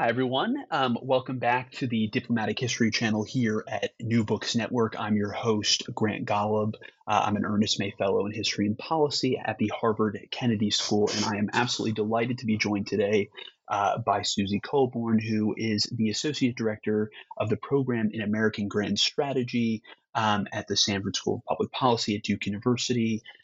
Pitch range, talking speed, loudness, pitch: 105-120 Hz, 180 wpm, -27 LUFS, 110 Hz